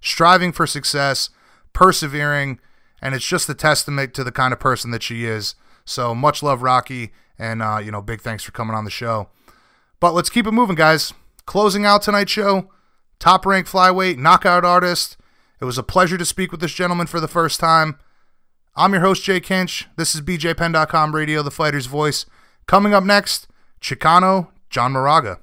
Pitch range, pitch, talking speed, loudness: 130-185 Hz, 160 Hz, 180 wpm, -17 LUFS